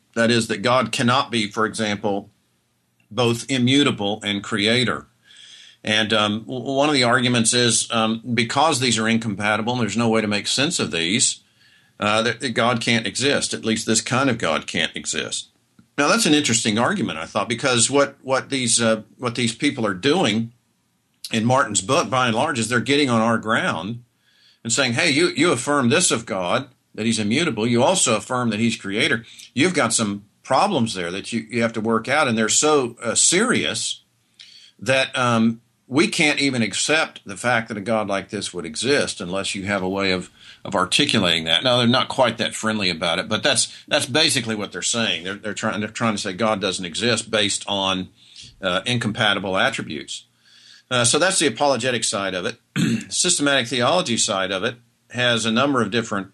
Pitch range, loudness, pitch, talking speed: 105-125 Hz, -20 LUFS, 115 Hz, 195 wpm